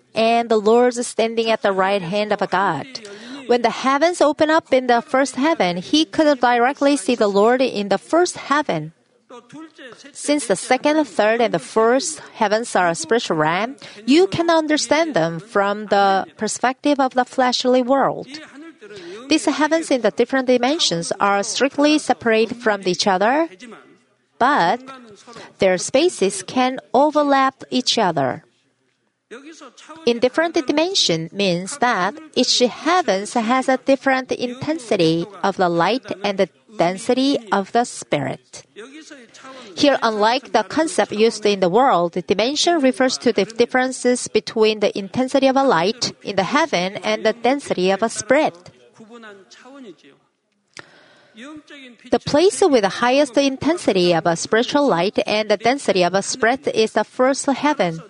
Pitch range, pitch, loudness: 205-280 Hz, 245 Hz, -18 LUFS